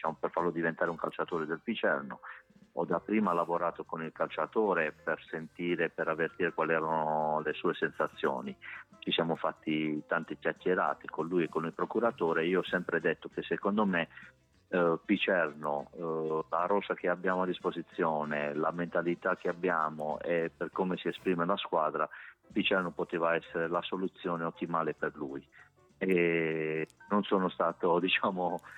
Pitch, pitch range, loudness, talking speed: 85 Hz, 80-90 Hz, -32 LUFS, 150 wpm